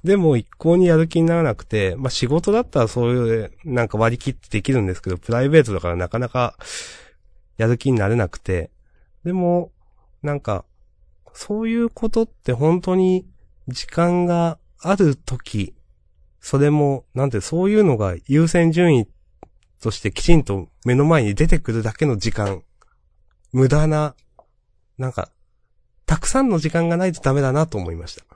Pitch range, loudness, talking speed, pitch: 105-165 Hz, -20 LUFS, 315 characters per minute, 130 Hz